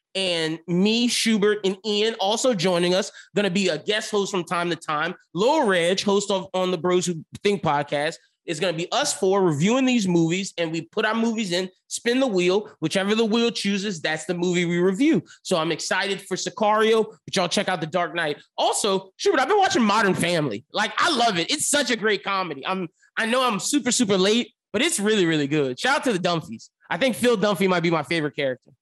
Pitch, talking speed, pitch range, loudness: 190 Hz, 225 wpm, 175-220 Hz, -22 LUFS